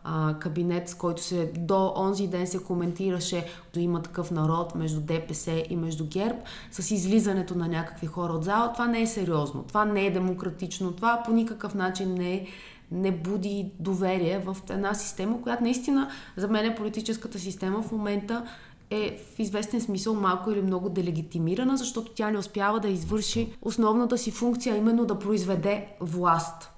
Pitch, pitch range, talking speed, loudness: 195 Hz, 175-215 Hz, 165 wpm, -28 LUFS